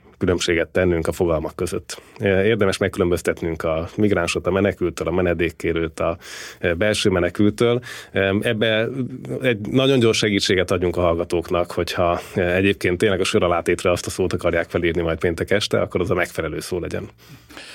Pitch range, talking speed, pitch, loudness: 85-110 Hz, 150 wpm, 95 Hz, -20 LUFS